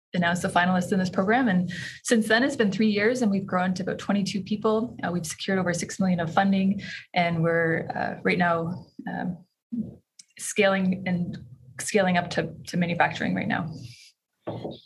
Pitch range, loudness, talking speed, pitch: 175-205 Hz, -25 LUFS, 175 wpm, 185 Hz